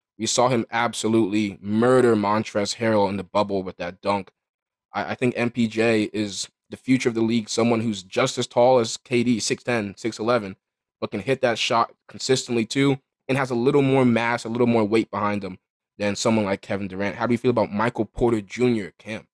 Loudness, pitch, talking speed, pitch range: -23 LUFS, 115 Hz, 200 wpm, 105-120 Hz